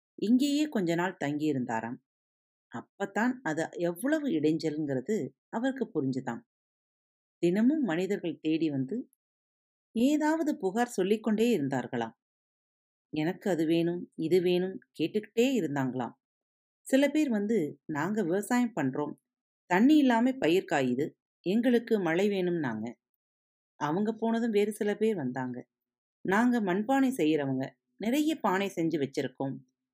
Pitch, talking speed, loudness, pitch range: 180 Hz, 105 wpm, -30 LUFS, 140-230 Hz